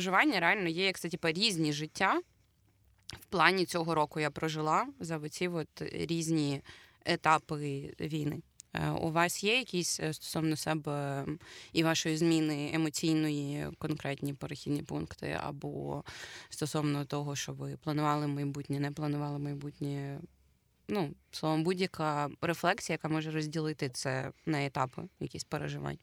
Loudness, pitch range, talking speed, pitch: -33 LUFS, 145-165 Hz, 125 wpm, 155 Hz